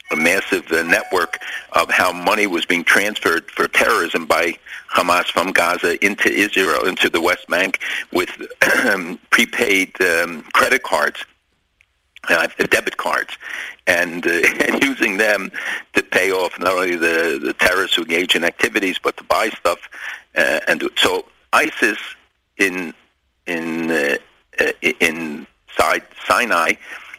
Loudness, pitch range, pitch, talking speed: -17 LUFS, 280-450 Hz, 360 Hz, 135 wpm